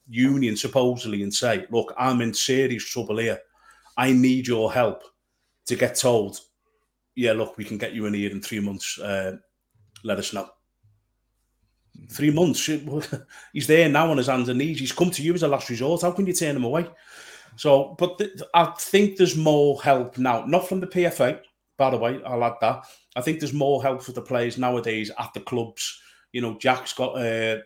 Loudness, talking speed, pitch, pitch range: -23 LUFS, 200 wpm, 130 Hz, 115-150 Hz